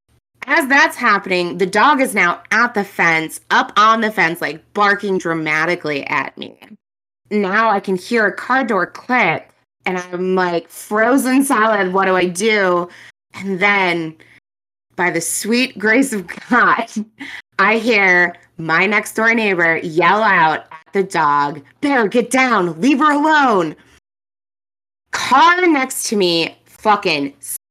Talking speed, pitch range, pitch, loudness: 145 wpm, 175-240 Hz, 200 Hz, -15 LUFS